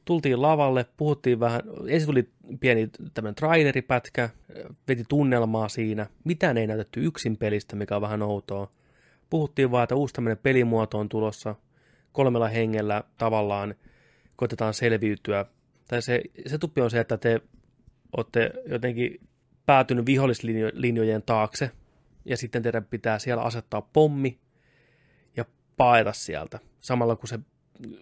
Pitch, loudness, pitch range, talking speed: 120 Hz, -26 LUFS, 110-130 Hz, 130 wpm